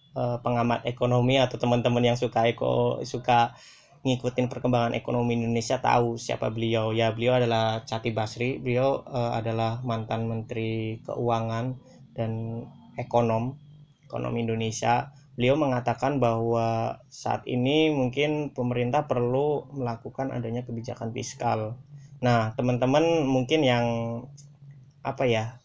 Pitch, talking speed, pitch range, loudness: 120 Hz, 110 wpm, 115-130 Hz, -26 LUFS